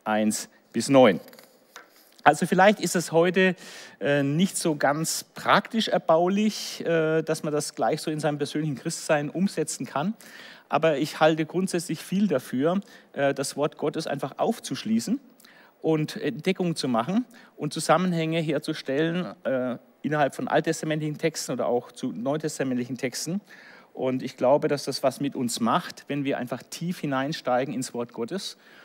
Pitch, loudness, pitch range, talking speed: 160 Hz, -26 LUFS, 140-185 Hz, 150 wpm